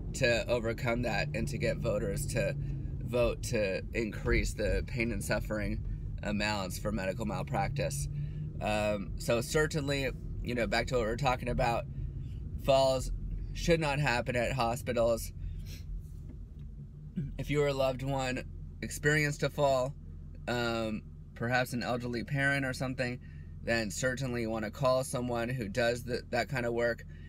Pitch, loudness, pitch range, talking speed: 120 Hz, -33 LUFS, 105-130 Hz, 145 wpm